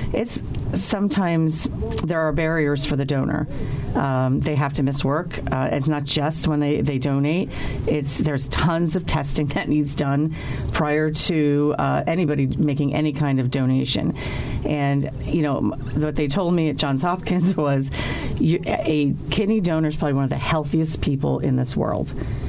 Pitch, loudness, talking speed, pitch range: 150 Hz, -22 LUFS, 170 wpm, 140-155 Hz